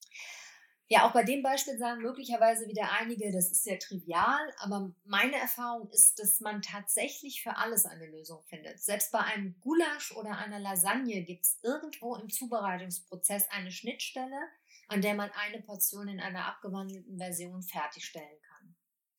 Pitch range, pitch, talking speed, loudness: 190-240 Hz, 205 Hz, 155 wpm, -31 LUFS